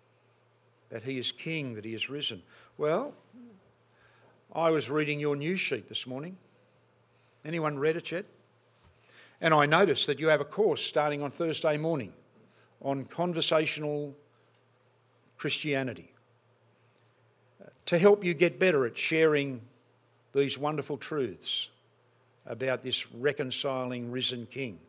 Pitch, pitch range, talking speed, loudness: 135 Hz, 120-155 Hz, 125 wpm, -29 LUFS